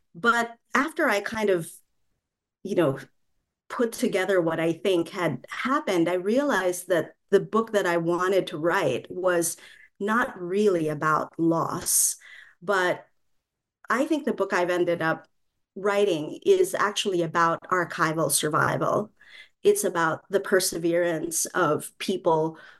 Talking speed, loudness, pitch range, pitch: 130 wpm, -25 LUFS, 170-230 Hz, 190 Hz